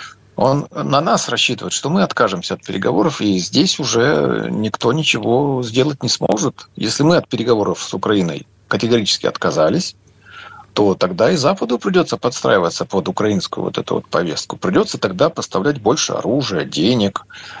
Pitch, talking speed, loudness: 130 Hz, 145 wpm, -17 LUFS